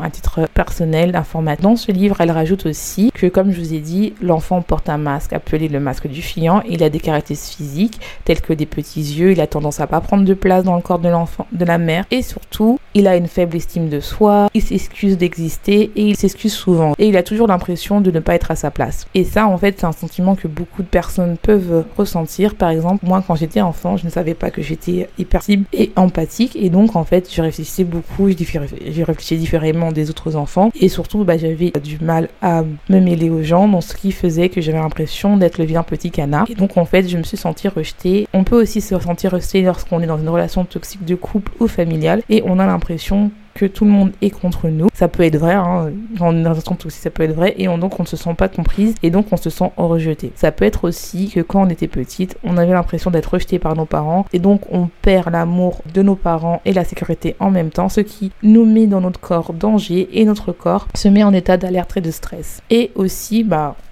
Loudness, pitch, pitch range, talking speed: -16 LUFS, 180 Hz, 165-195 Hz, 245 wpm